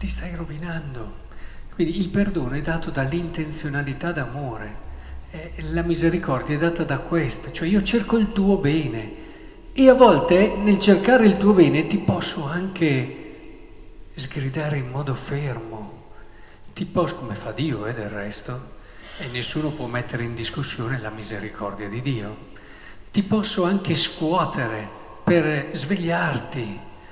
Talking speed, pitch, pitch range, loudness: 135 wpm, 150 Hz, 115-175 Hz, -22 LUFS